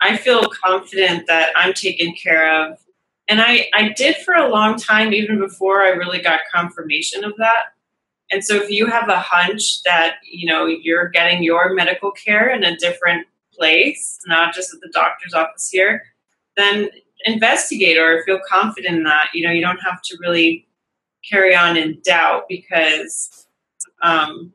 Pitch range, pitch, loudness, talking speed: 170-205 Hz, 180 Hz, -15 LUFS, 170 wpm